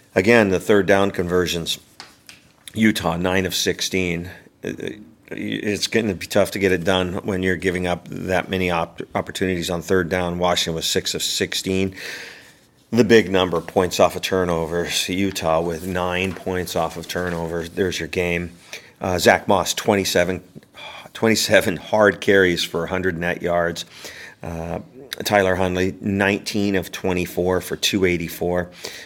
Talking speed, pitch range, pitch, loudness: 145 wpm, 85-95 Hz, 90 Hz, -20 LUFS